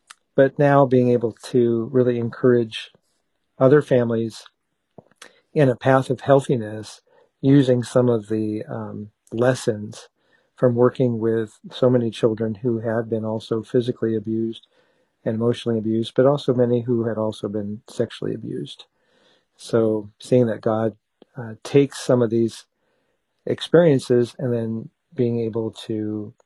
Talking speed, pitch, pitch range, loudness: 135 wpm, 120 Hz, 110-125 Hz, -21 LUFS